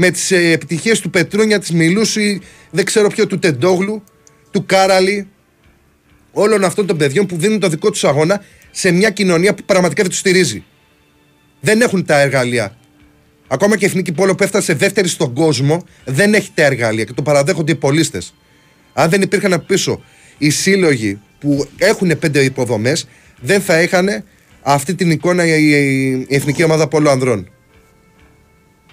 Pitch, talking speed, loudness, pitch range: 170 Hz, 155 wpm, -14 LUFS, 145-195 Hz